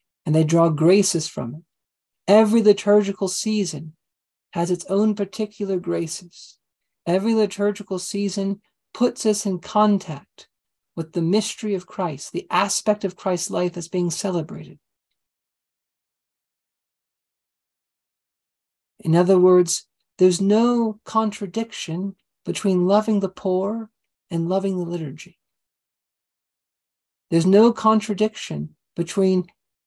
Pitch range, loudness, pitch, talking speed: 170-210 Hz, -21 LUFS, 190 Hz, 105 wpm